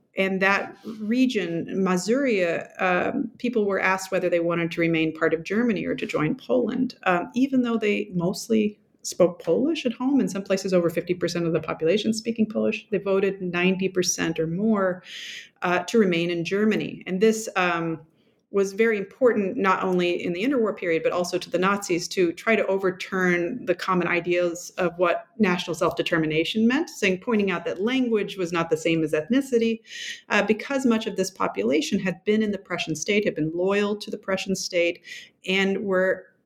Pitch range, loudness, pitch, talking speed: 175-220 Hz, -24 LUFS, 190 Hz, 185 wpm